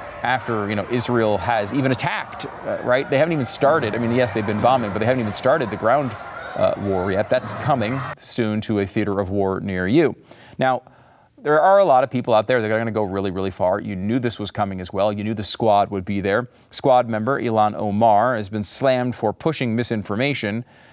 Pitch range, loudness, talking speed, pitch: 105-125 Hz, -20 LUFS, 230 wpm, 110 Hz